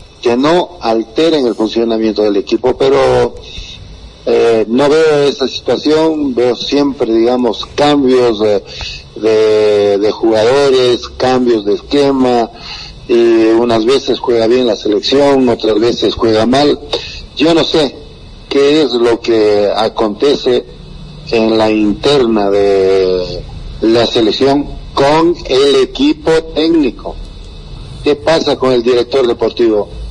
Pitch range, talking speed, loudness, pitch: 110-140 Hz, 120 wpm, -11 LUFS, 120 Hz